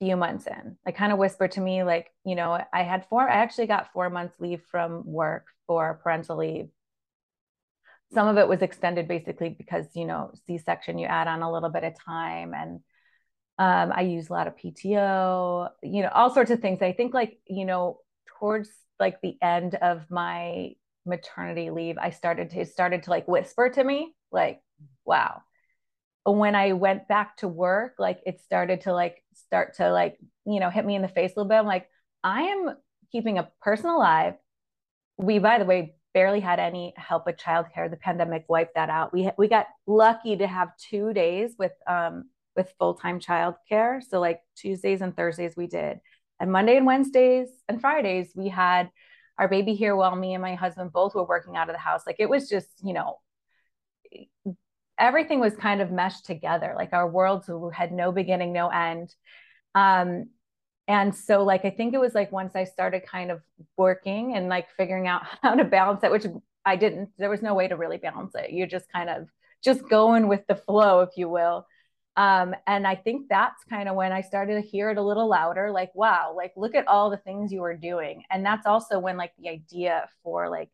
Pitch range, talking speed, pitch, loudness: 175-210 Hz, 205 wpm, 185 Hz, -25 LUFS